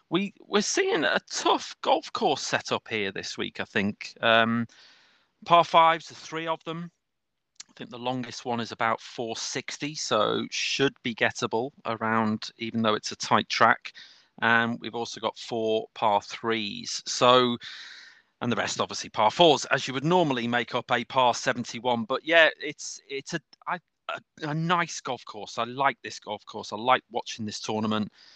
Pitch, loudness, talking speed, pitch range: 125 Hz, -26 LUFS, 175 wpm, 115-160 Hz